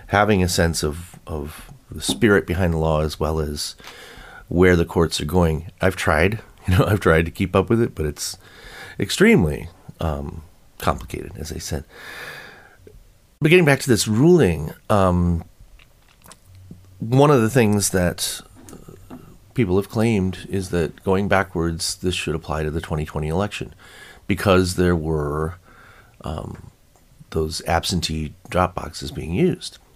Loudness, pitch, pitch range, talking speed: -20 LUFS, 90 Hz, 80-105 Hz, 145 wpm